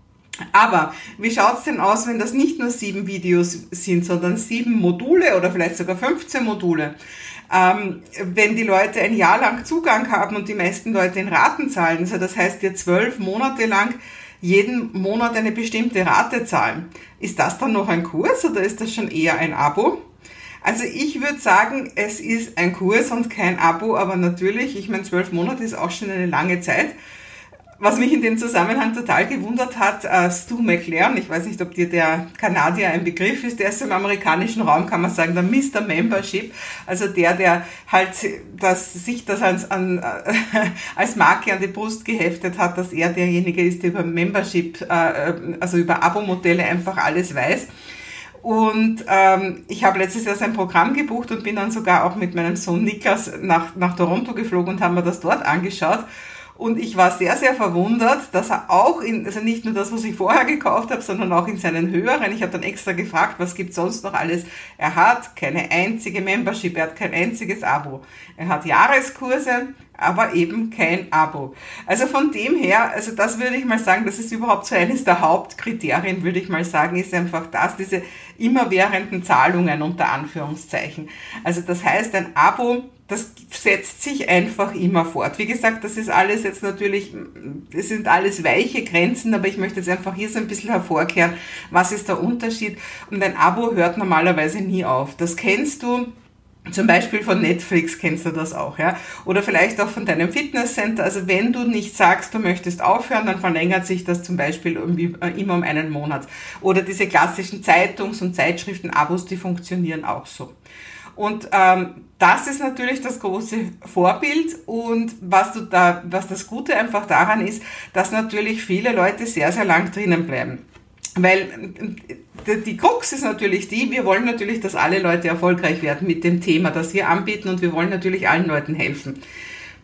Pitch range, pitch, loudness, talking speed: 175-220 Hz, 190 Hz, -19 LUFS, 185 wpm